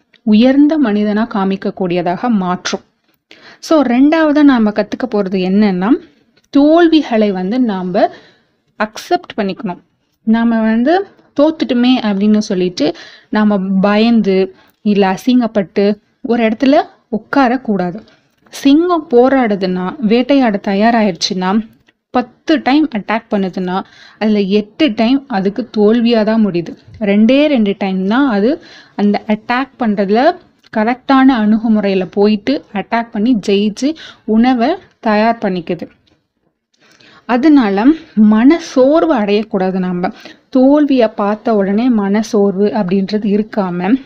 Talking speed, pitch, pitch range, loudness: 100 wpm, 220 Hz, 205-265 Hz, -13 LUFS